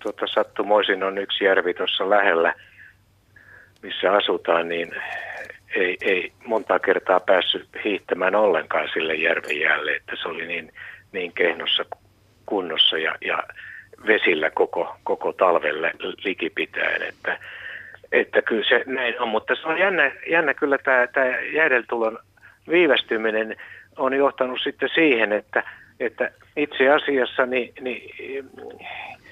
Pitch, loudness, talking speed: 170 Hz, -21 LUFS, 115 wpm